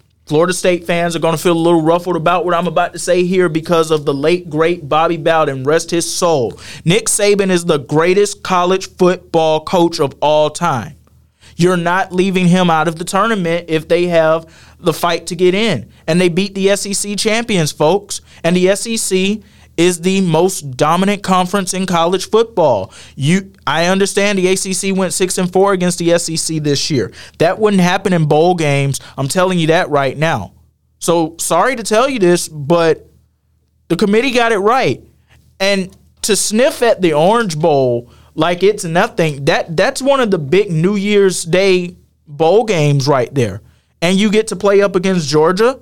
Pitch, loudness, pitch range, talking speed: 175 Hz, -14 LUFS, 160-190 Hz, 185 wpm